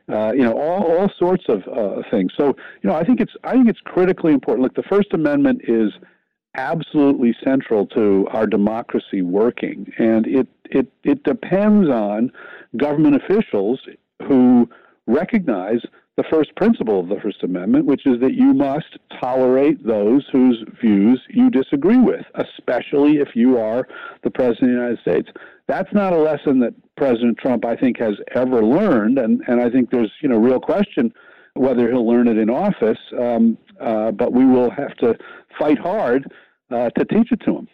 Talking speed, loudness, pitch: 180 wpm, -18 LUFS, 140 Hz